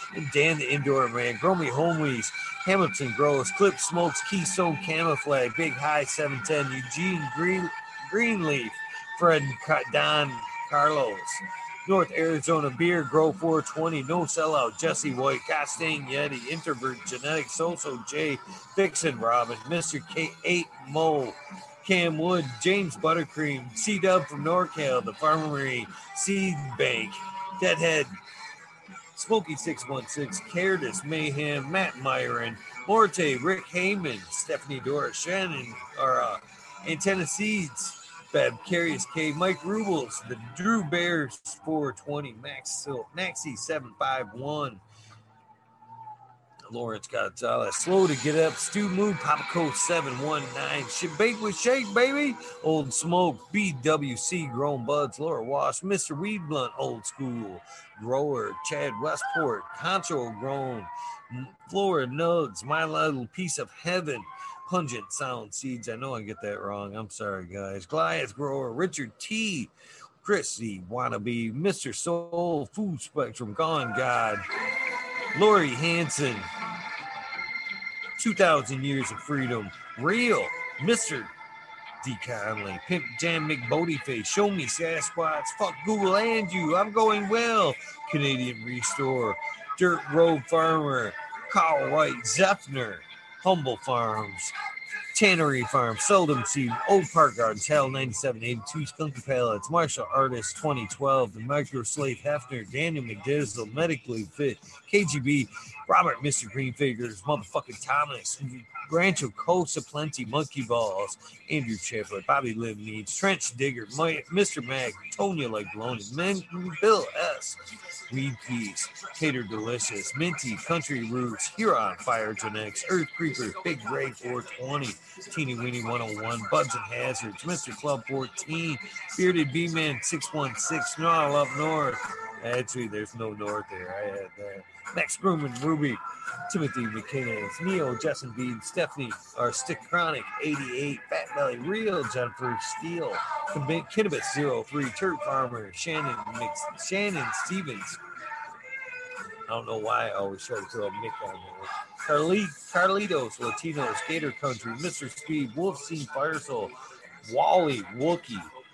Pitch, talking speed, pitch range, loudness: 155 Hz, 125 wpm, 130-190 Hz, -28 LUFS